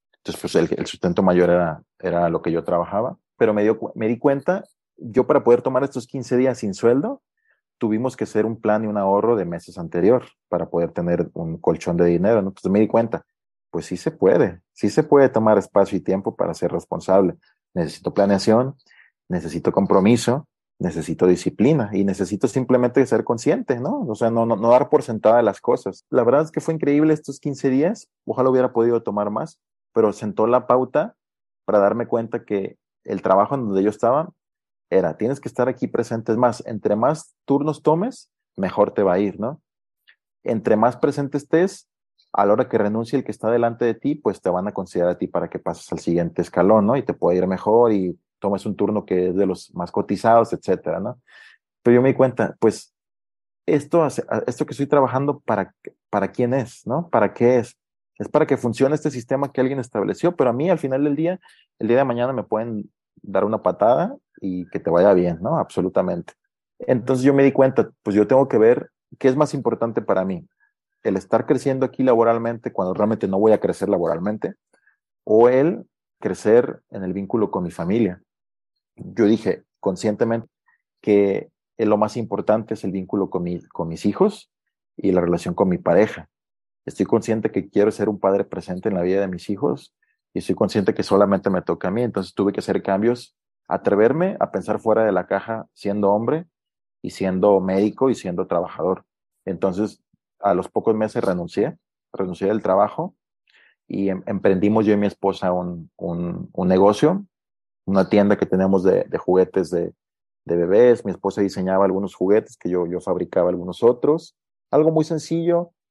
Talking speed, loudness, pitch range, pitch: 195 wpm, -20 LUFS, 100-130 Hz, 110 Hz